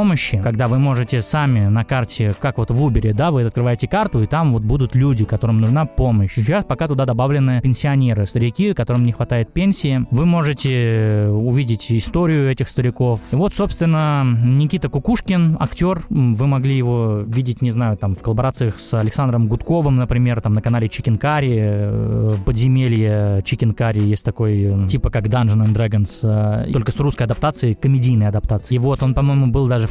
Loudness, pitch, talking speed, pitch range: -17 LUFS, 125 Hz, 170 wpm, 115-140 Hz